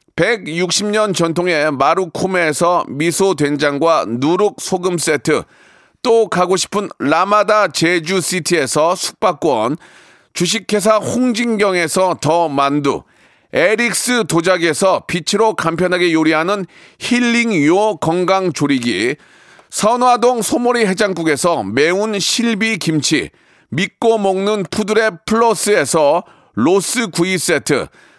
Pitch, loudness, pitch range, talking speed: 185 Hz, -15 LUFS, 165-215 Hz, 240 characters per minute